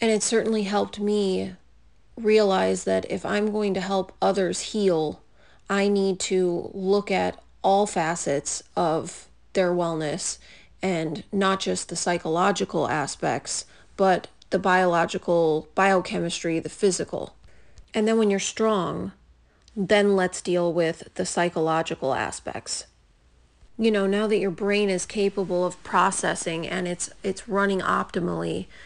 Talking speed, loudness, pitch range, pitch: 130 wpm, -24 LUFS, 165-200 Hz, 185 Hz